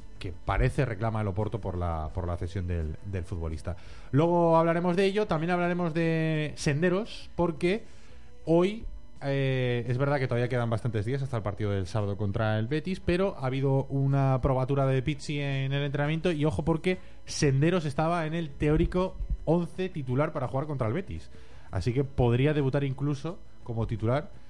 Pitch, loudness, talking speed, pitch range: 135 Hz, -29 LUFS, 175 wpm, 110-160 Hz